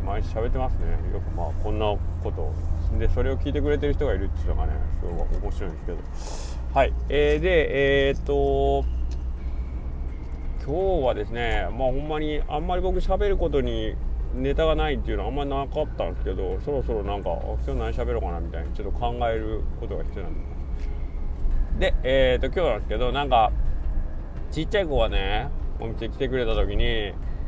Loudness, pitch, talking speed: -26 LUFS, 80 Hz, 380 characters per minute